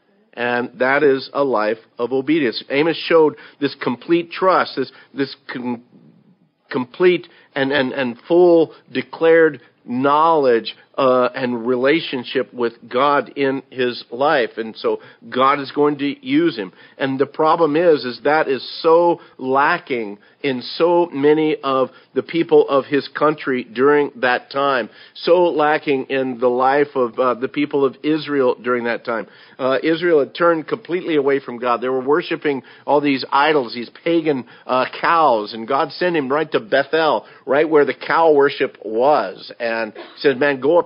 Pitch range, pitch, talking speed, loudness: 130-160 Hz, 140 Hz, 160 wpm, -18 LUFS